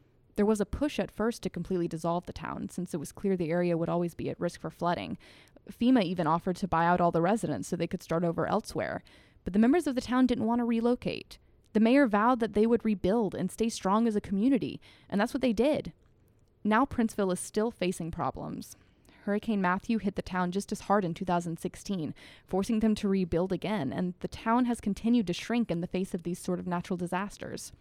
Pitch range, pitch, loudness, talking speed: 175-225 Hz, 195 Hz, -30 LUFS, 225 wpm